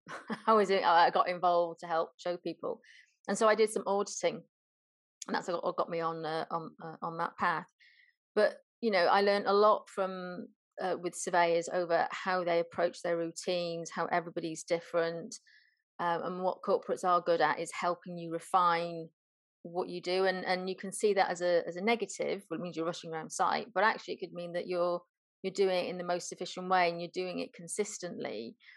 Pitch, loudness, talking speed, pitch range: 175 Hz, -32 LUFS, 205 wpm, 170-195 Hz